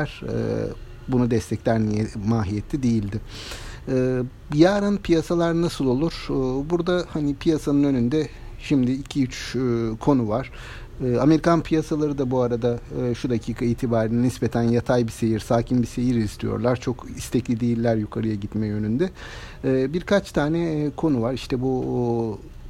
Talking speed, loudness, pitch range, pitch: 120 wpm, -23 LUFS, 115-145 Hz, 125 Hz